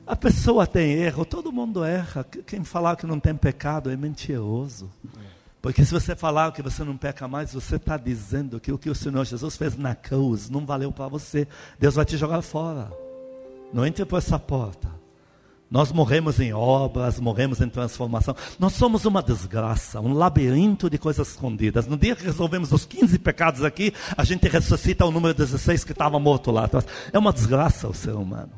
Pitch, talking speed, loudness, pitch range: 140 Hz, 190 wpm, -23 LUFS, 125-160 Hz